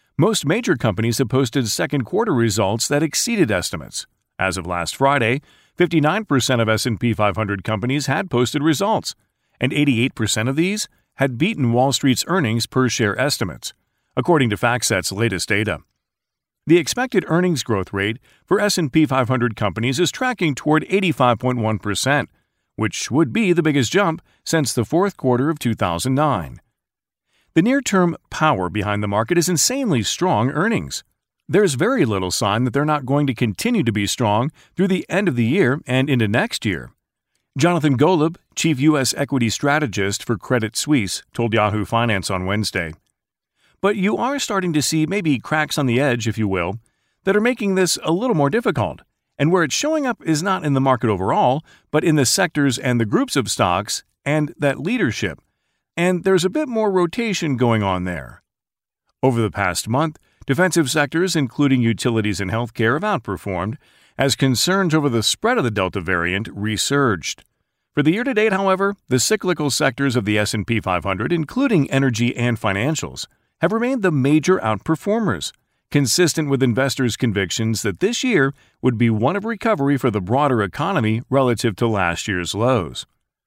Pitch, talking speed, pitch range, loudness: 130 Hz, 165 wpm, 110-160 Hz, -19 LUFS